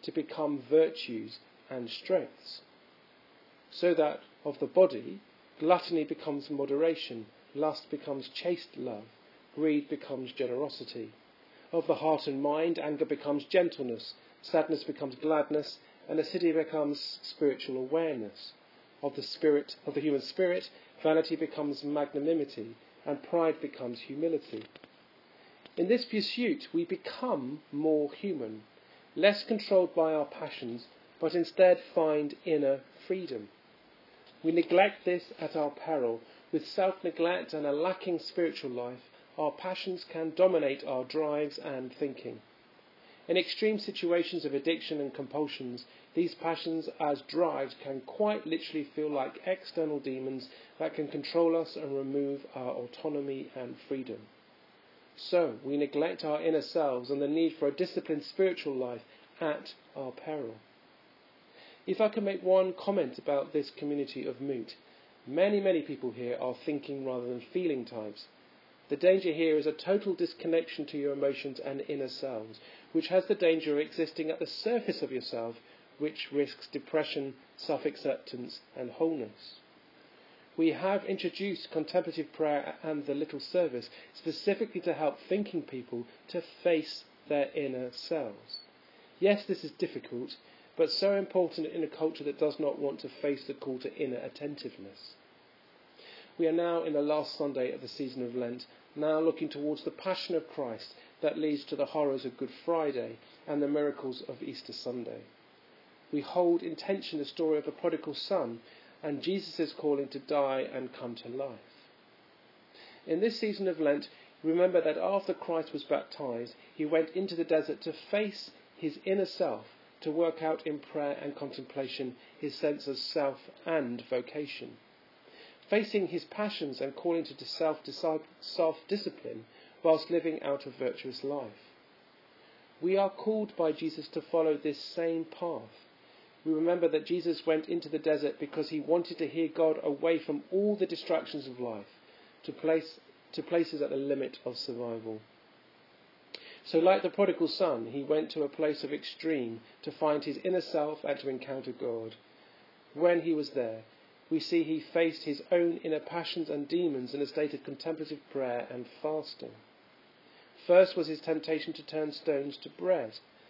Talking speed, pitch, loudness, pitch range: 155 wpm, 155 Hz, -33 LUFS, 140-170 Hz